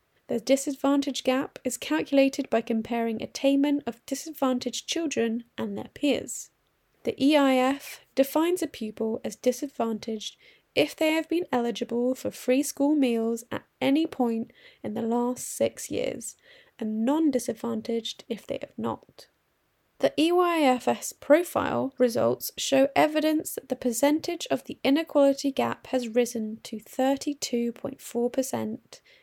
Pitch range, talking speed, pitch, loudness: 235-290 Hz, 125 wpm, 265 Hz, -27 LUFS